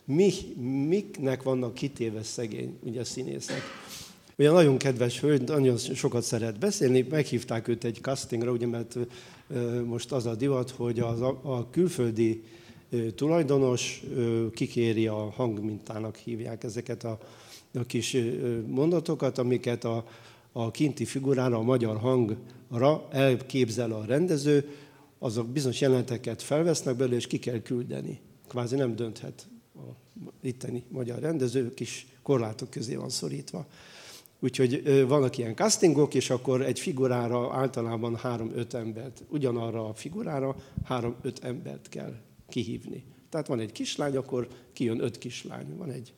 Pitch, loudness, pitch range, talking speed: 125 Hz, -29 LUFS, 120-135 Hz, 130 wpm